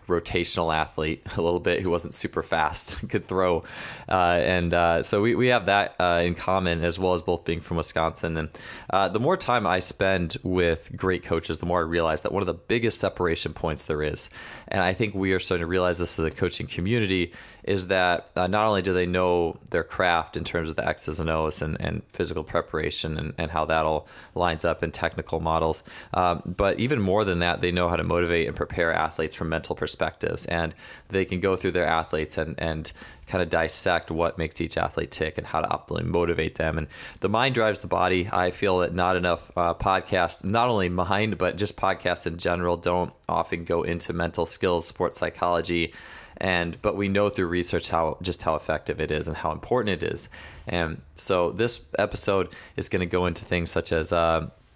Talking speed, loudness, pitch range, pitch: 215 wpm, -25 LUFS, 80-95 Hz, 85 Hz